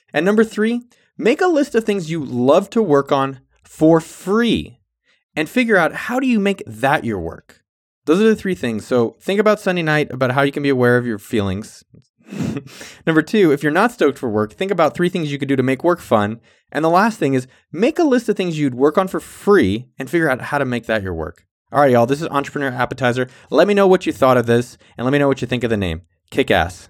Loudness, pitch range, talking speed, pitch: -17 LUFS, 120-190 Hz, 255 wpm, 140 Hz